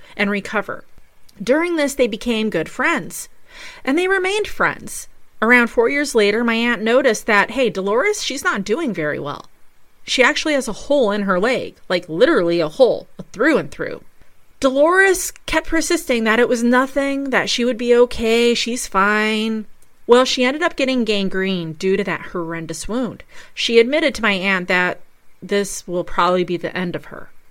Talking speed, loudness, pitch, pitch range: 175 wpm, -18 LUFS, 235 Hz, 200-275 Hz